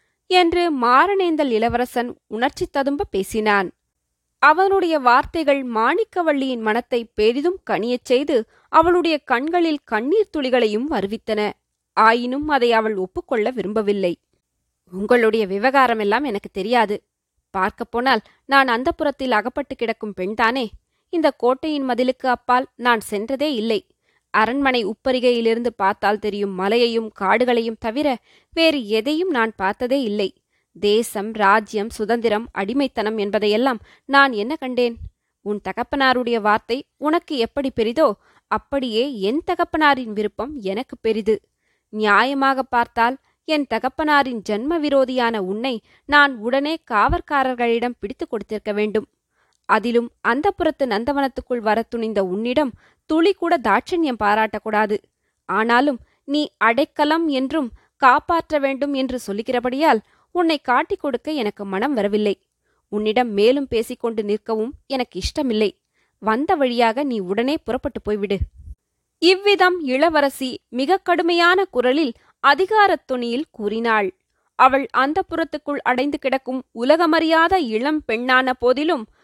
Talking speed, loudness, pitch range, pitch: 105 wpm, -19 LUFS, 220-290 Hz, 250 Hz